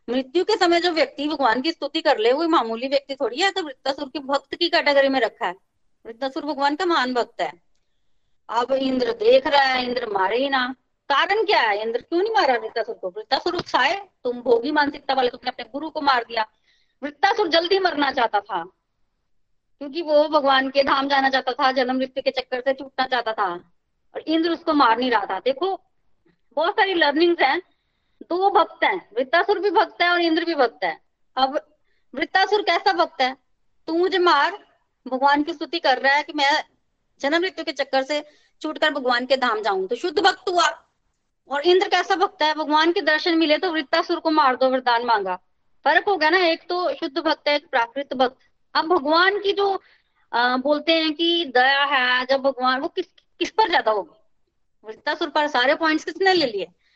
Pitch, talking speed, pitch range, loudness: 300 Hz, 200 wpm, 265-345 Hz, -21 LUFS